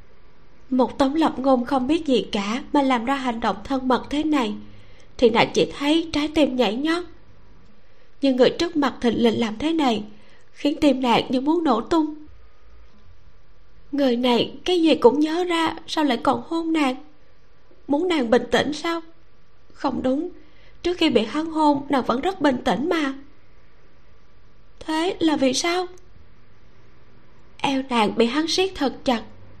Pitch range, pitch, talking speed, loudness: 240-315 Hz, 275 Hz, 165 wpm, -22 LUFS